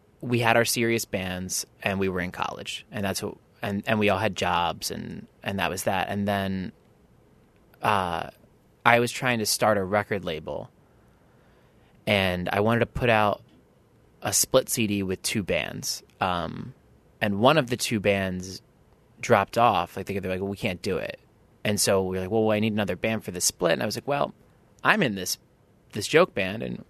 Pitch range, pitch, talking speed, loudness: 95-115 Hz, 105 Hz, 200 wpm, -25 LUFS